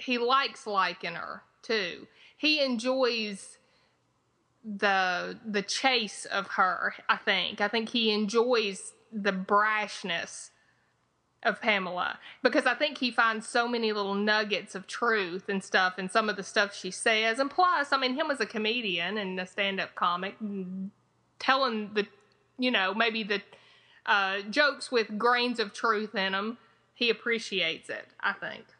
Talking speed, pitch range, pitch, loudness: 150 wpm, 200-240 Hz, 215 Hz, -28 LUFS